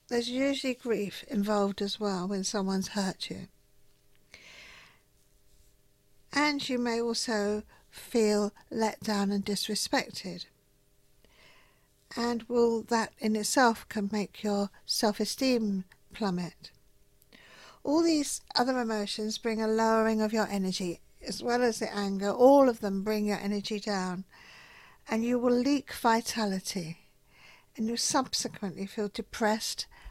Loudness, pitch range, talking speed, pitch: -30 LUFS, 200-240 Hz, 120 wpm, 215 Hz